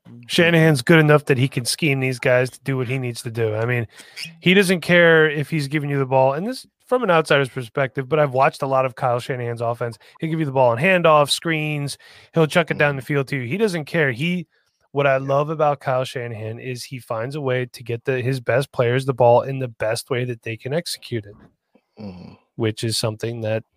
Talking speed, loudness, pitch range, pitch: 235 wpm, -20 LUFS, 120-155 Hz, 135 Hz